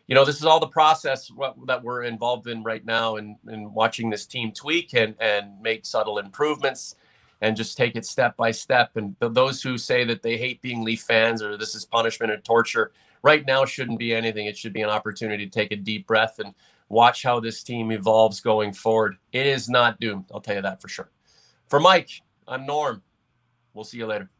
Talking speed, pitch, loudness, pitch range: 215 wpm, 115 Hz, -23 LUFS, 110-125 Hz